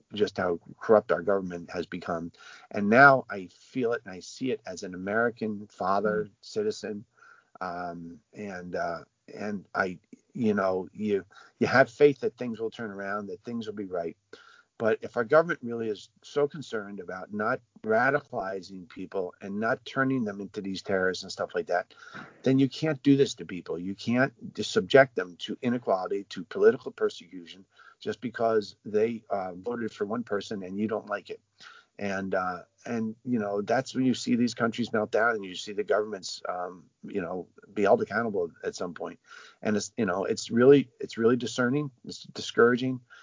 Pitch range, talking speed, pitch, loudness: 100-140 Hz, 185 wpm, 115 Hz, -28 LUFS